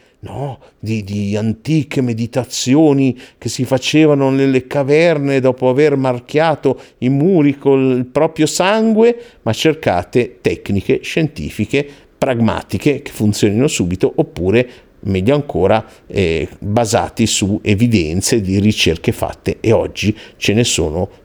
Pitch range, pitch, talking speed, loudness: 105-140 Hz, 125 Hz, 115 wpm, -15 LUFS